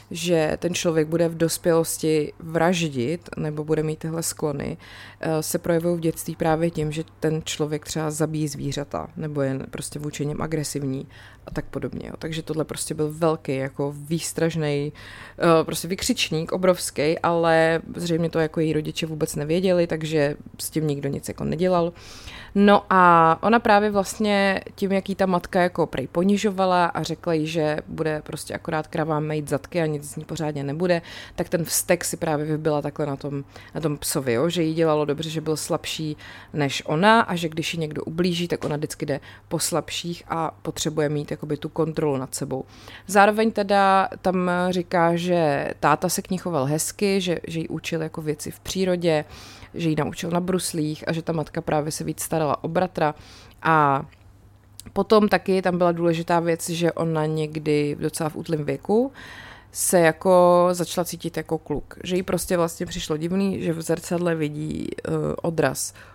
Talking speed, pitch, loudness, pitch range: 180 wpm, 160 Hz, -23 LUFS, 150-175 Hz